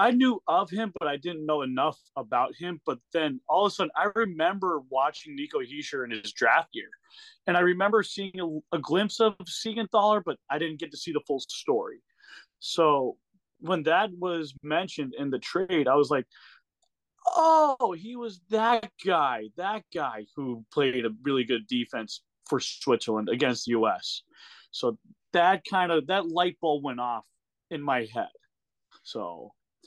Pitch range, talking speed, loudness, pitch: 150-235 Hz, 175 wpm, -27 LUFS, 185 Hz